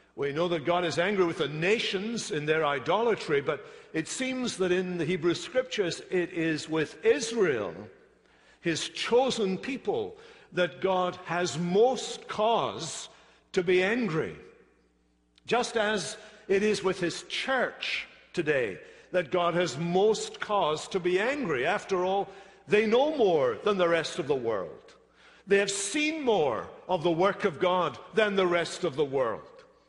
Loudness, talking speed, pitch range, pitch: -28 LUFS, 155 wpm, 175-255 Hz, 190 Hz